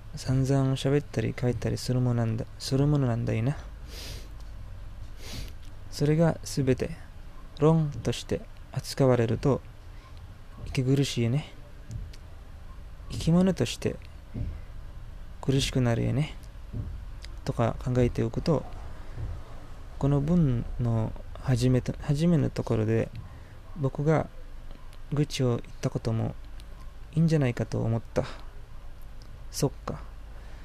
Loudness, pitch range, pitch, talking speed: -28 LUFS, 95-135 Hz, 115 Hz, 205 characters per minute